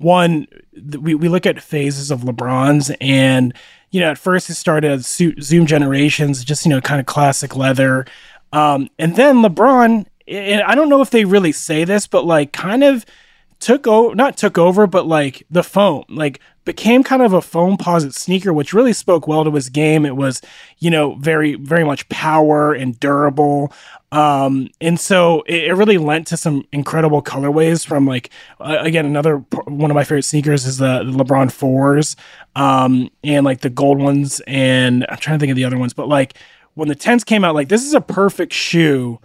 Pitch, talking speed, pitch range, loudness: 150 Hz, 195 wpm, 140-175 Hz, -14 LUFS